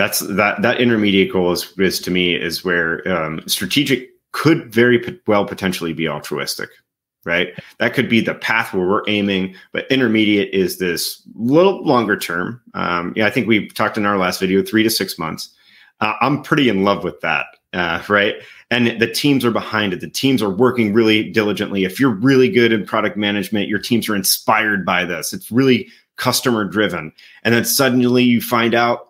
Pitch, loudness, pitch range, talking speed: 110 Hz, -17 LUFS, 100-120 Hz, 195 wpm